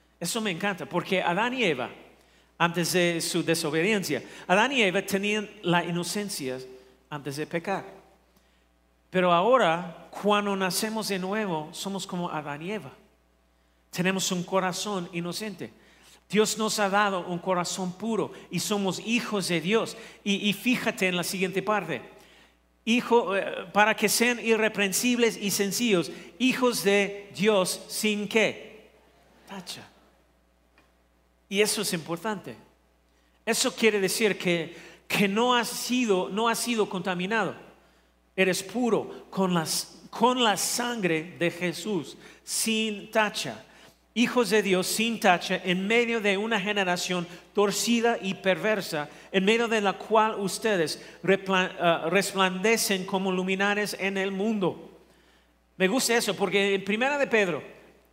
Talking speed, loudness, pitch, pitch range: 130 wpm, -26 LUFS, 195 Hz, 175-215 Hz